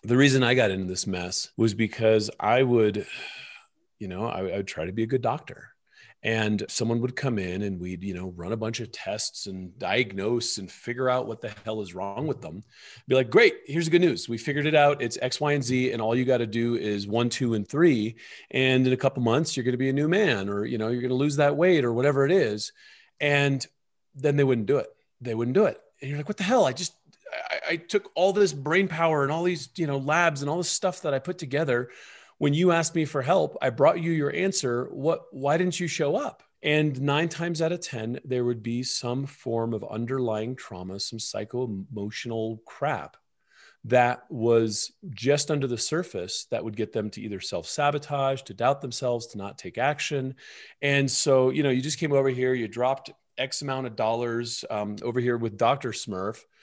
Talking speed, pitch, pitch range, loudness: 230 wpm, 130 Hz, 115-150 Hz, -26 LUFS